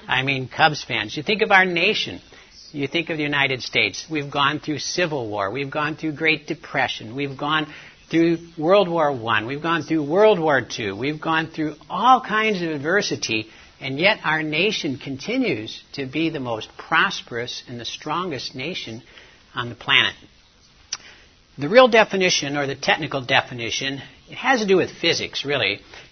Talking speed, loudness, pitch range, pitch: 170 wpm, -21 LUFS, 135-170 Hz, 150 Hz